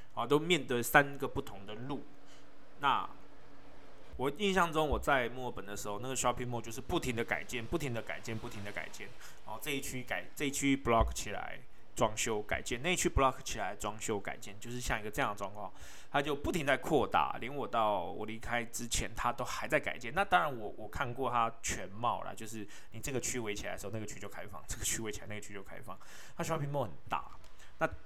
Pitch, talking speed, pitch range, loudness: 120 Hz, 380 characters per minute, 105-140 Hz, -35 LUFS